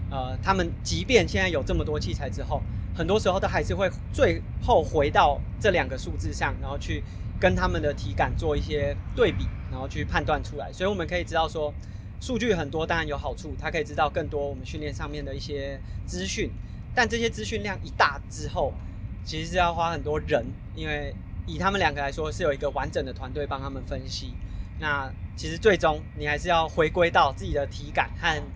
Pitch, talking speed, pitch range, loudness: 105 Hz, 315 characters per minute, 95-140 Hz, -27 LUFS